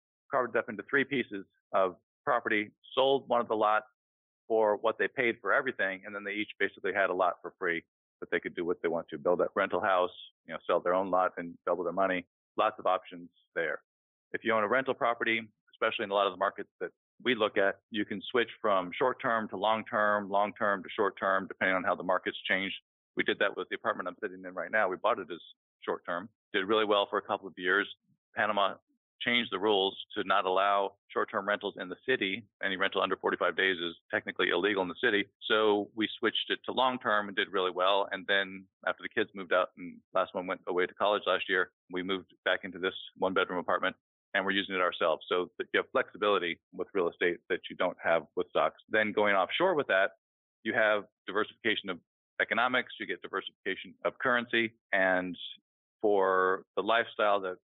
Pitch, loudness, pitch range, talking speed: 100 Hz, -31 LUFS, 95-110 Hz, 220 wpm